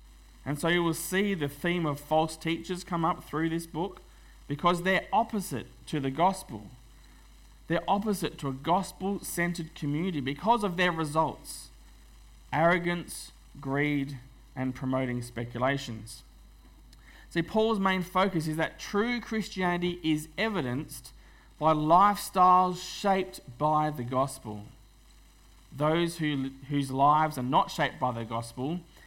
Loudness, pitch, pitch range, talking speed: -29 LUFS, 155 Hz, 135-180 Hz, 130 wpm